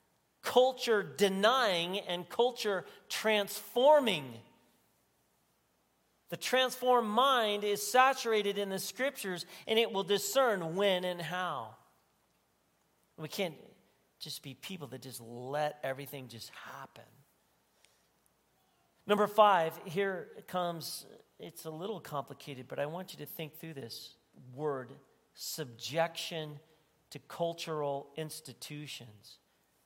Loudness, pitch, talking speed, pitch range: -32 LUFS, 170 Hz, 105 wpm, 145-205 Hz